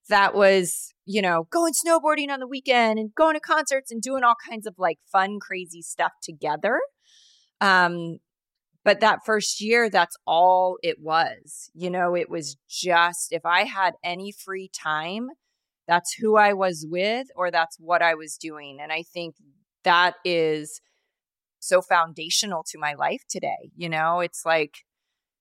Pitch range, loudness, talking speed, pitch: 165-225 Hz, -23 LUFS, 165 wpm, 185 Hz